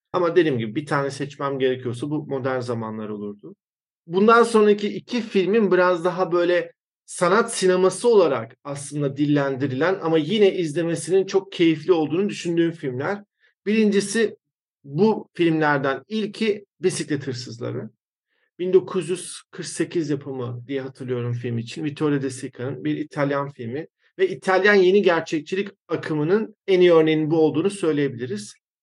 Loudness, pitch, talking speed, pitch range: -22 LUFS, 165 Hz, 125 wpm, 140-190 Hz